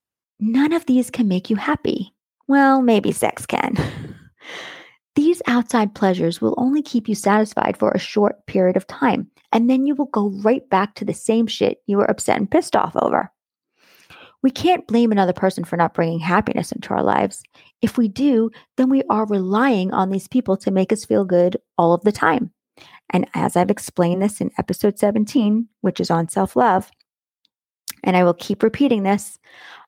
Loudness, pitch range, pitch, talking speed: -19 LUFS, 190-250 Hz, 215 Hz, 185 wpm